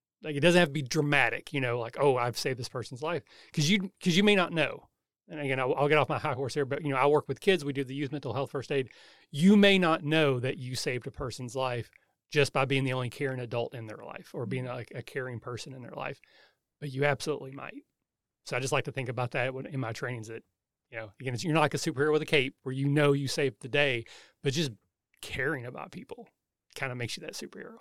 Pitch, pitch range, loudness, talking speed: 140 Hz, 125-150 Hz, -29 LUFS, 265 wpm